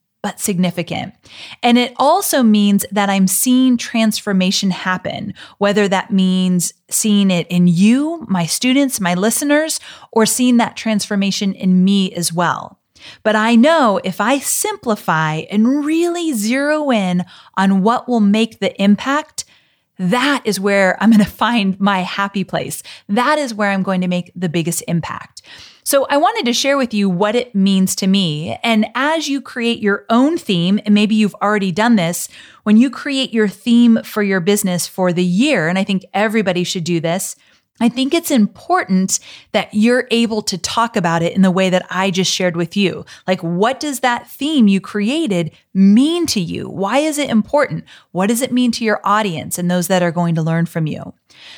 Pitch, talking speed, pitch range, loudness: 205 Hz, 185 wpm, 185-240 Hz, -16 LUFS